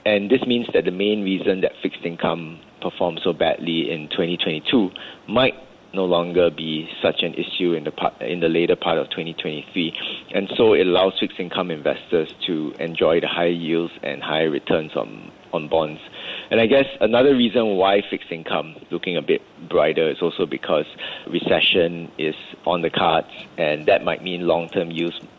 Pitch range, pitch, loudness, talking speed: 85-100 Hz, 85 Hz, -21 LUFS, 180 wpm